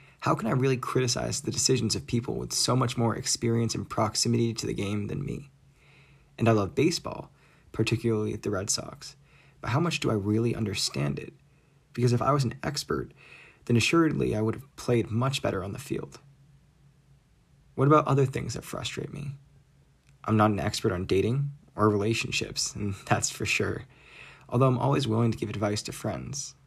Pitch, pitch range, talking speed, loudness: 125 Hz, 110-140 Hz, 185 wpm, -27 LUFS